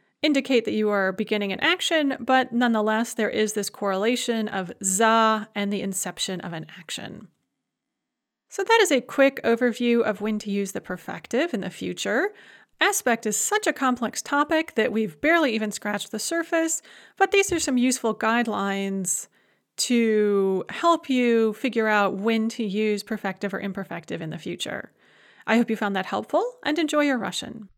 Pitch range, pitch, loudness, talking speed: 205-270 Hz, 225 Hz, -24 LUFS, 170 wpm